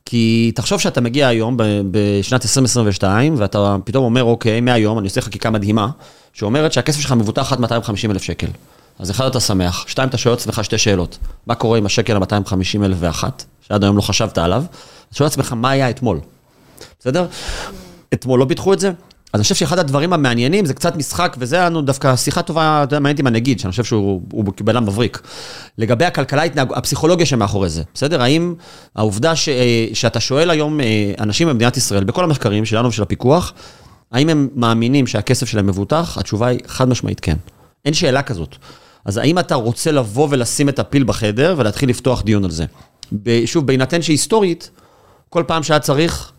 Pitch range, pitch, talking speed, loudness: 105-145 Hz, 120 Hz, 180 wpm, -16 LUFS